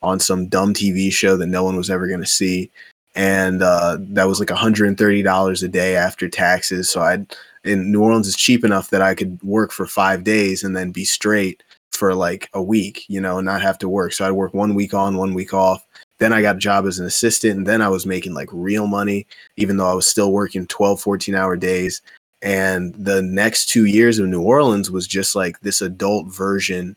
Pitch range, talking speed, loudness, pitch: 95-100 Hz, 230 wpm, -17 LUFS, 95 Hz